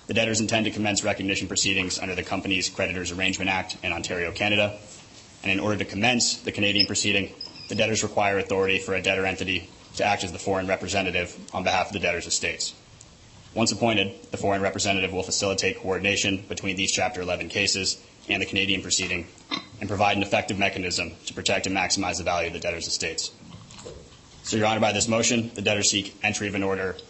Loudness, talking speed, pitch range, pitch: -24 LUFS, 195 wpm, 95-105 Hz, 100 Hz